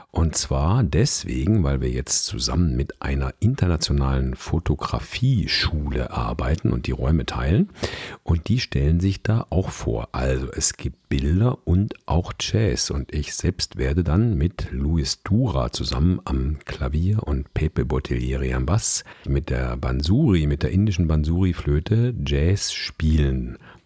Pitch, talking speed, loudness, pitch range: 75 Hz, 140 wpm, -23 LUFS, 65-90 Hz